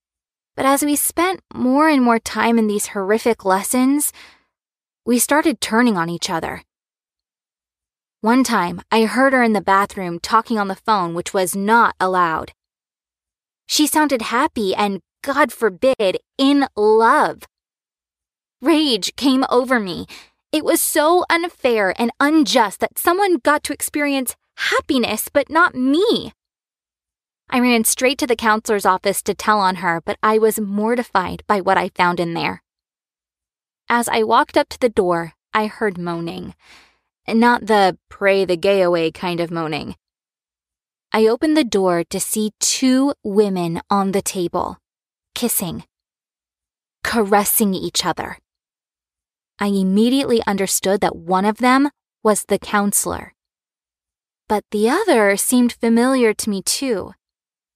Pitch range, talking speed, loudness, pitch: 195-260 Hz, 140 wpm, -17 LUFS, 220 Hz